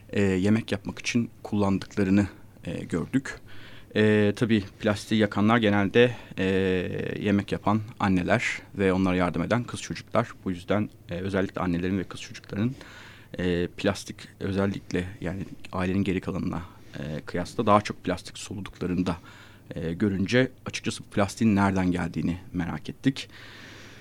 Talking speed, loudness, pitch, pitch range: 130 wpm, -27 LUFS, 100 Hz, 95-110 Hz